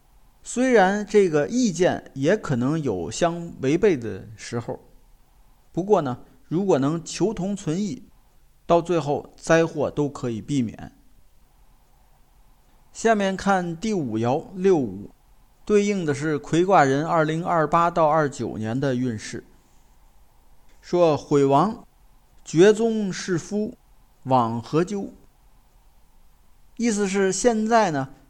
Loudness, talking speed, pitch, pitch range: -22 LUFS, 165 characters per minute, 165 Hz, 135-195 Hz